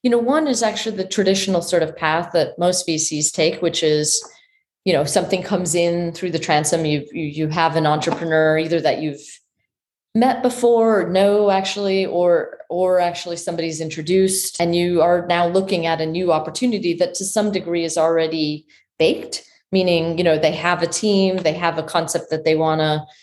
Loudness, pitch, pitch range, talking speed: -19 LUFS, 170 Hz, 160-190 Hz, 190 wpm